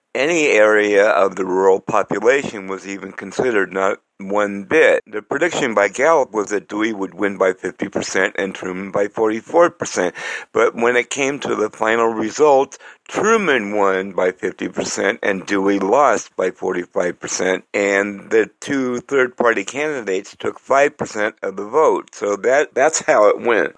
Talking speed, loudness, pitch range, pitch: 170 wpm, -18 LUFS, 100-120 Hz, 105 Hz